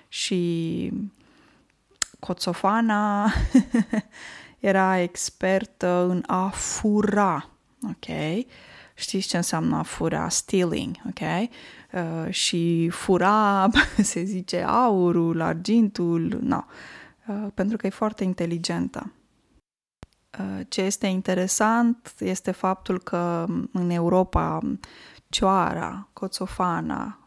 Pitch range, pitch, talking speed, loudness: 180-215 Hz, 190 Hz, 90 wpm, -24 LUFS